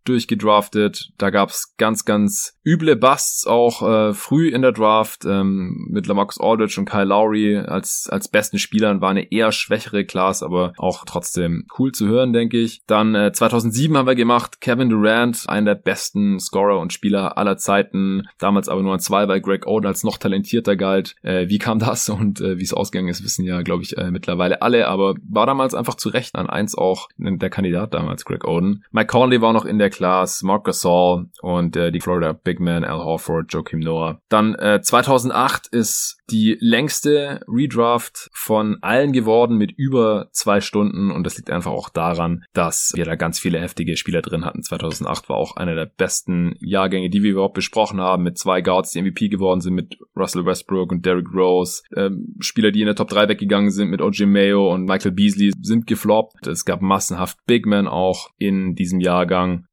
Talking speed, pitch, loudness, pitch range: 195 wpm, 100 Hz, -18 LUFS, 90-110 Hz